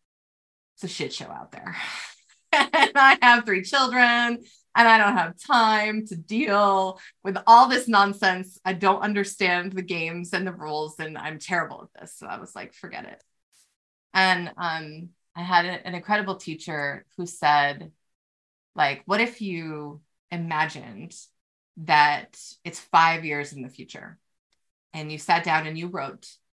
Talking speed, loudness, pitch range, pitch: 155 wpm, -22 LUFS, 155-200 Hz, 180 Hz